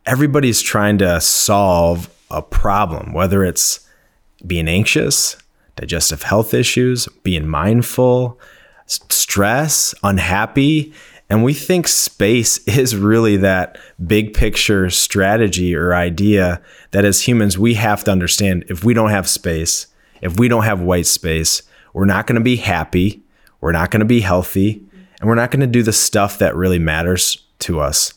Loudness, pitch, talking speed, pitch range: -15 LUFS, 100 Hz, 155 wpm, 90-115 Hz